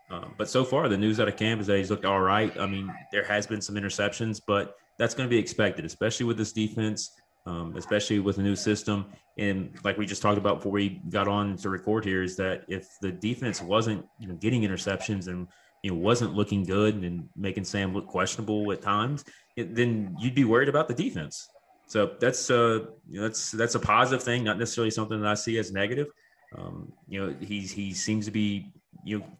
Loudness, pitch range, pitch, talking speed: -28 LUFS, 100-115 Hz, 105 Hz, 225 wpm